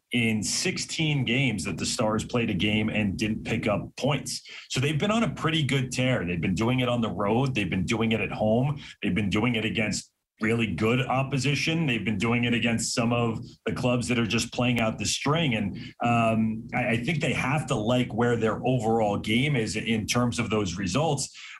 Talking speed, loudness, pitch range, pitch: 215 wpm, -26 LUFS, 110-130 Hz, 120 Hz